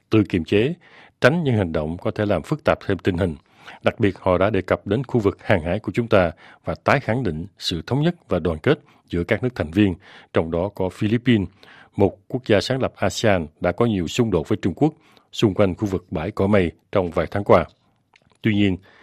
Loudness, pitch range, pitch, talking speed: -21 LUFS, 90-120 Hz, 105 Hz, 235 wpm